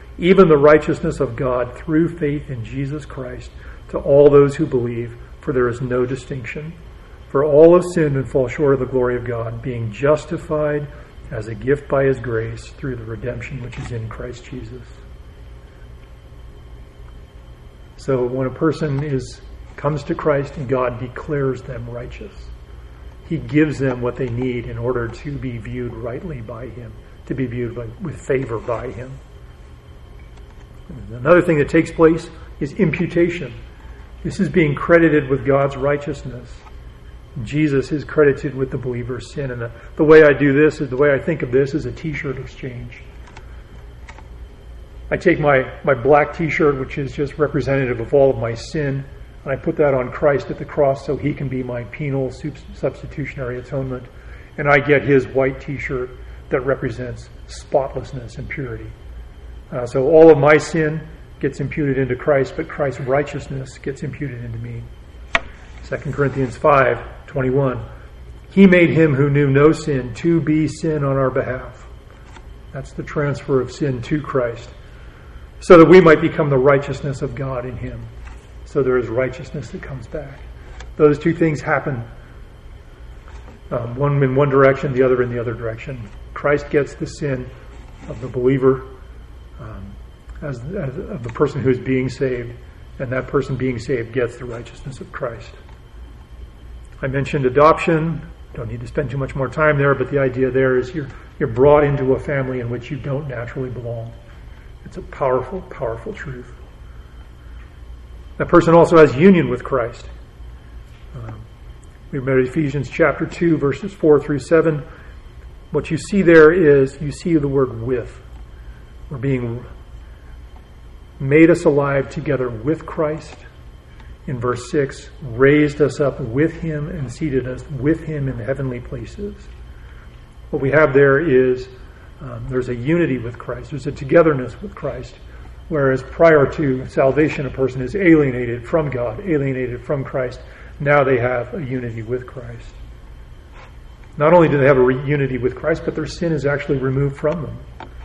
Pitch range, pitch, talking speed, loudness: 120-145 Hz, 130 Hz, 165 wpm, -18 LUFS